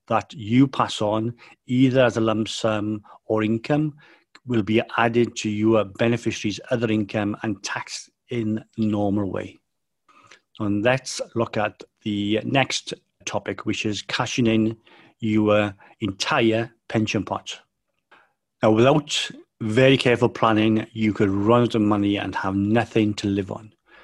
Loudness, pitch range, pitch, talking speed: -22 LUFS, 105-120 Hz, 110 Hz, 140 wpm